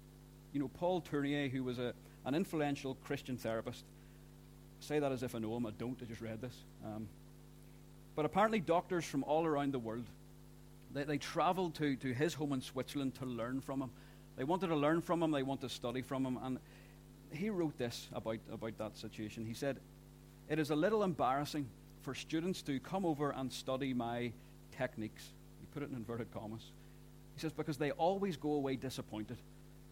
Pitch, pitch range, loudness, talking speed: 135 Hz, 120-150 Hz, -39 LUFS, 195 wpm